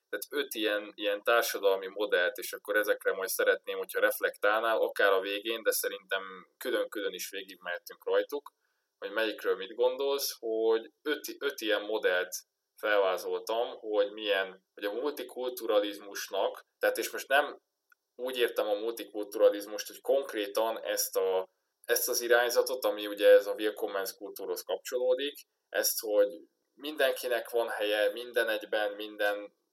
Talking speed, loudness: 135 wpm, -31 LUFS